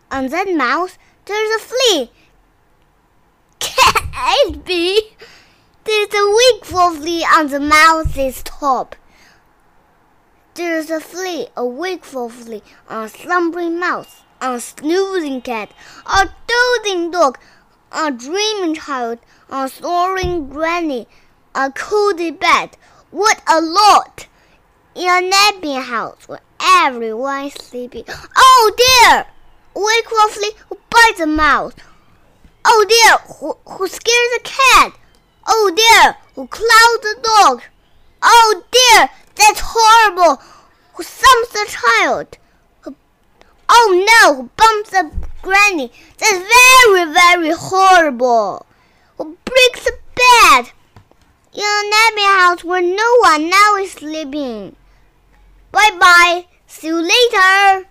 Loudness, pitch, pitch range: -12 LUFS, 375 Hz, 315-430 Hz